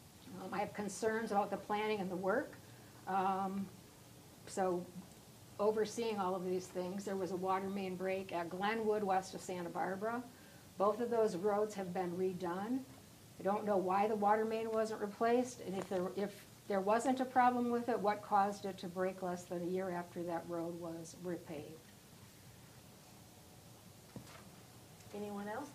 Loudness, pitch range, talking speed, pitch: -38 LUFS, 185-210 Hz, 165 wpm, 195 Hz